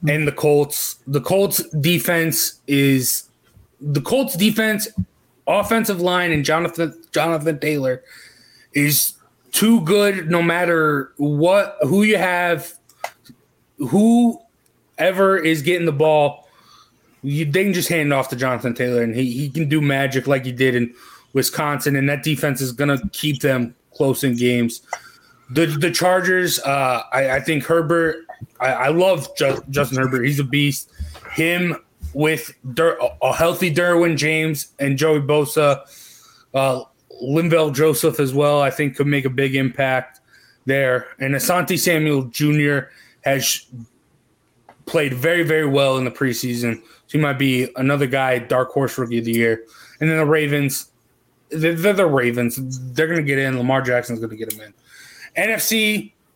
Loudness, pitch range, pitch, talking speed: -19 LUFS, 130-165 Hz, 145 Hz, 155 wpm